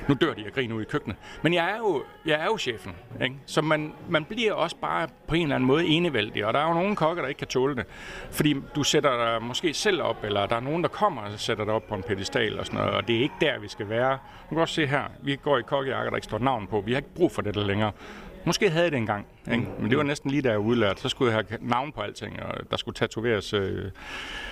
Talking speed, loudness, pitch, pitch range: 290 wpm, -26 LUFS, 130 Hz, 110-155 Hz